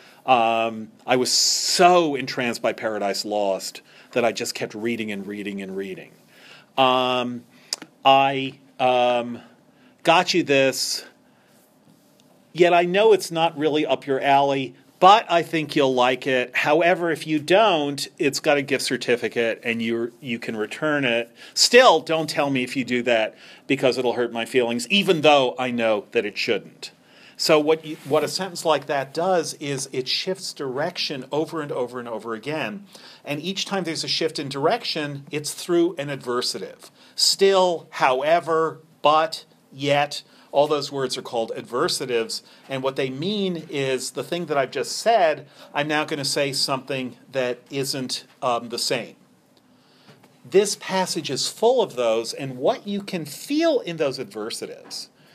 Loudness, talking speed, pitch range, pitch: -22 LUFS, 165 wpm, 125-160 Hz, 140 Hz